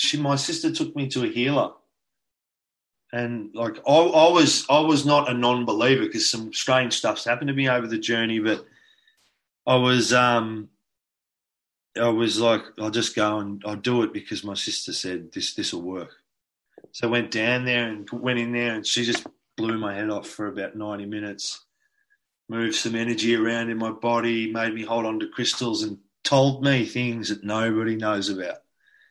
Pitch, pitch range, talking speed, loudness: 115 Hz, 110-125 Hz, 185 wpm, -23 LUFS